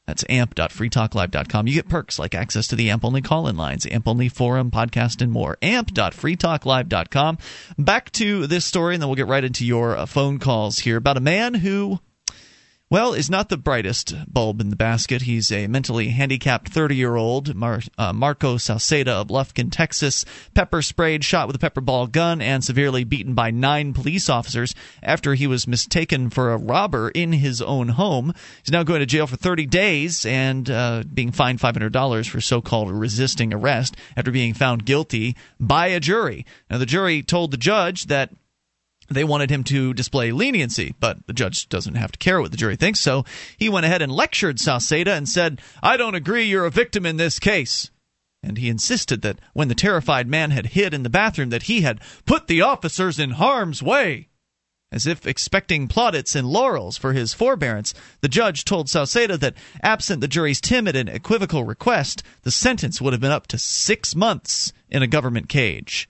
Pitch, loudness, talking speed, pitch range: 135 Hz, -20 LUFS, 190 wpm, 120-165 Hz